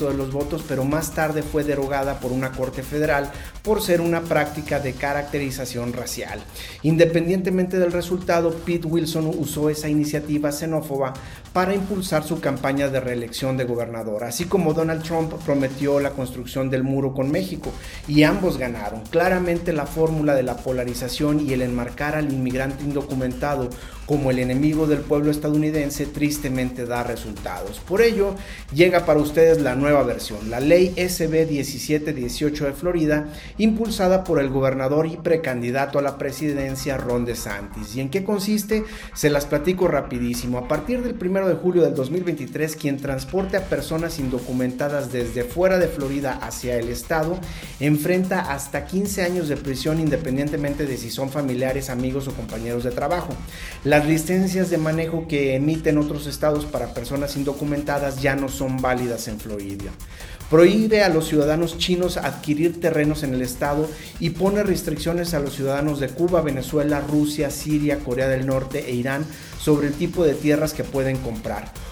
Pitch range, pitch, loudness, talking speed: 130-165 Hz, 145 Hz, -22 LUFS, 160 wpm